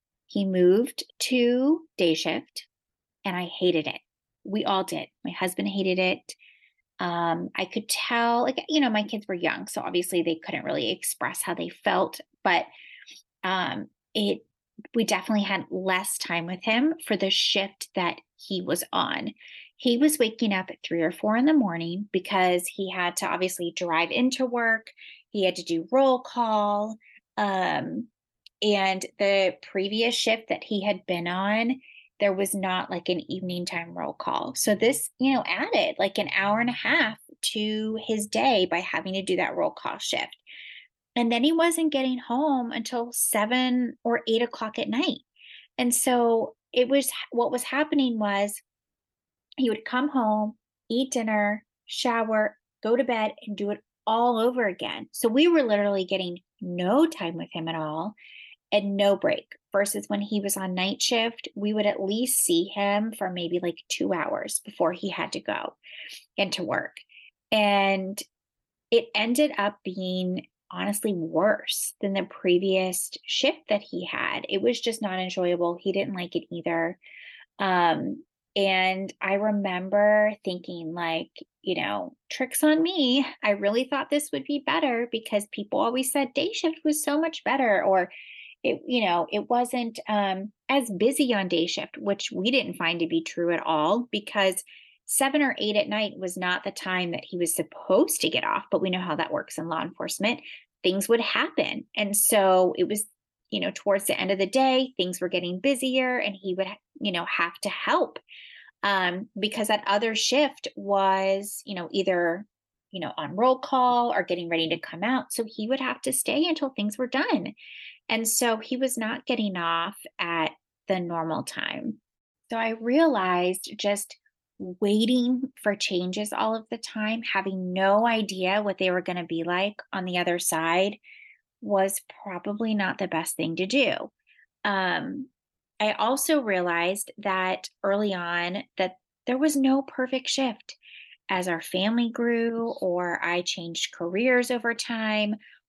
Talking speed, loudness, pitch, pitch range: 170 wpm, -26 LUFS, 205 Hz, 185-245 Hz